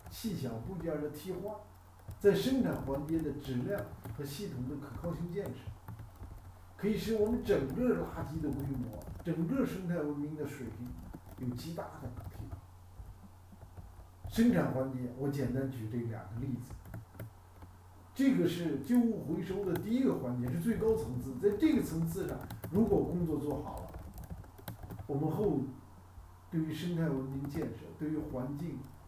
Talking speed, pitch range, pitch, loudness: 225 characters per minute, 100-165 Hz, 130 Hz, -35 LUFS